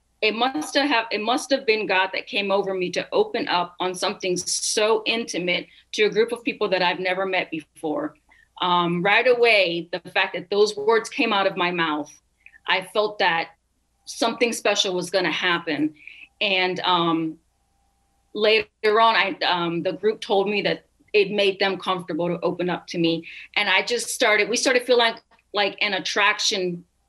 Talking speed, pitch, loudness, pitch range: 185 wpm, 195 Hz, -22 LUFS, 175-220 Hz